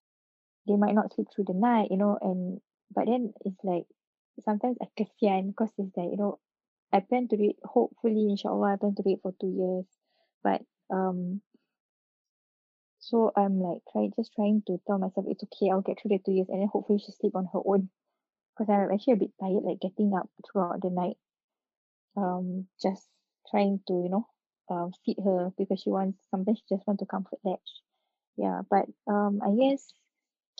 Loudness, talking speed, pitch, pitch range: -29 LUFS, 200 wpm, 200 Hz, 190-215 Hz